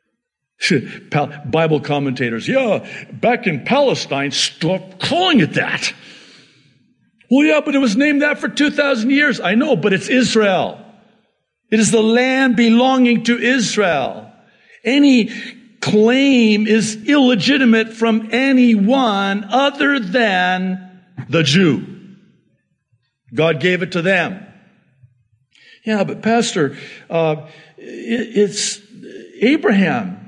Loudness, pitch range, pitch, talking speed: -15 LUFS, 180-245 Hz, 215 Hz, 105 wpm